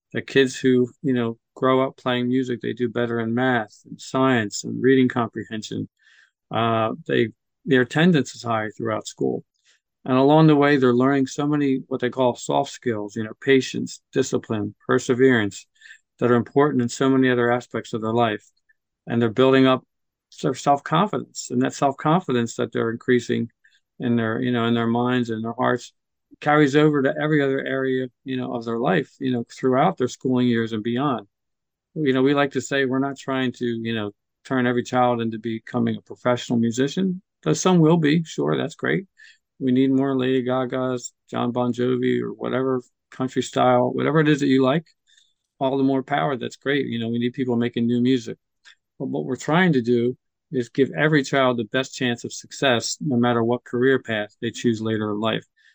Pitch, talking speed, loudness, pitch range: 125 Hz, 195 wpm, -22 LUFS, 120-135 Hz